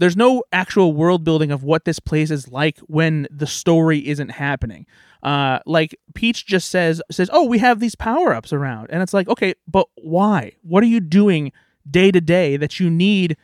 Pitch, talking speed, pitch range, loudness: 170 Hz, 195 wpm, 150-195 Hz, -18 LUFS